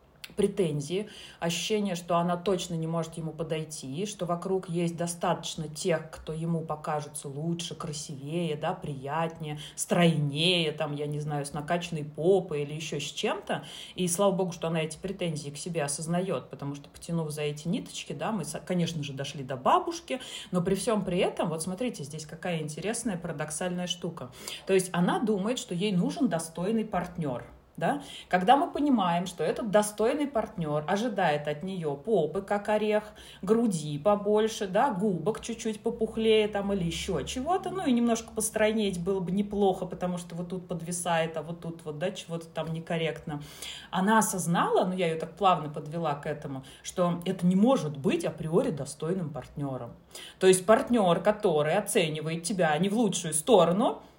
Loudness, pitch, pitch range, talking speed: -29 LUFS, 175 Hz, 155-205 Hz, 165 wpm